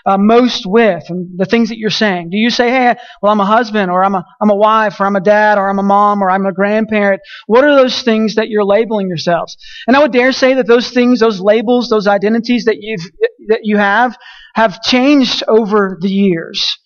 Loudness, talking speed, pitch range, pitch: -12 LUFS, 230 wpm, 200-240 Hz, 220 Hz